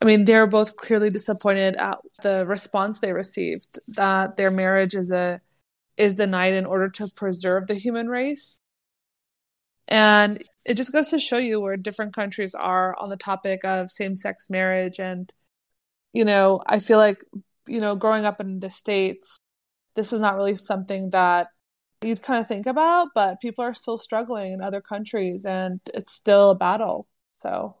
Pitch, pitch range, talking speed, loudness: 205 Hz, 190-220 Hz, 175 wpm, -22 LUFS